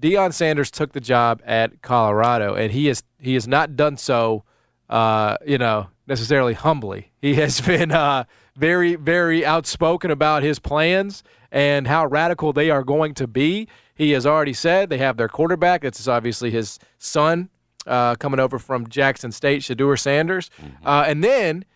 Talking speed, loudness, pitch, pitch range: 175 wpm, -19 LUFS, 140 Hz, 125-160 Hz